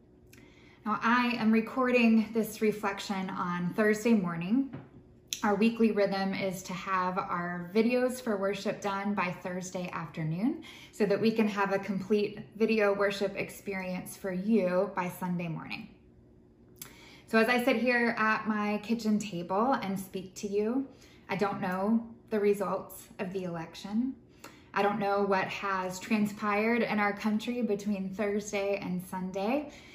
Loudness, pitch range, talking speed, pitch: -30 LUFS, 190-220 Hz, 145 wpm, 200 Hz